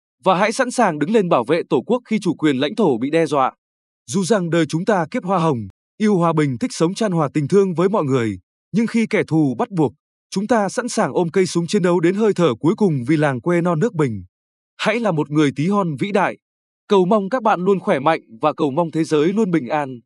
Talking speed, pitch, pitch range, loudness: 260 wpm, 170 Hz, 150-205 Hz, -19 LUFS